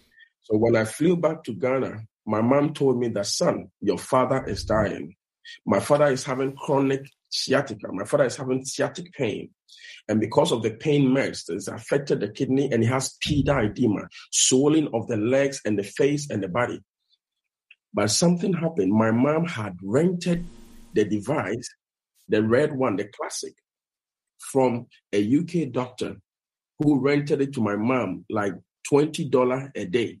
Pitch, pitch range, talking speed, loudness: 135 Hz, 110-150 Hz, 165 wpm, -24 LUFS